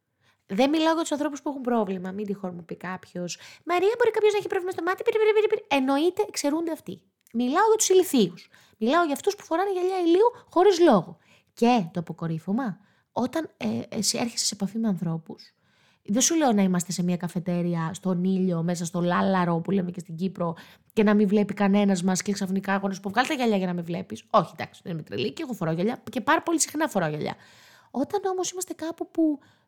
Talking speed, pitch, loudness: 210 wpm, 220 Hz, -25 LUFS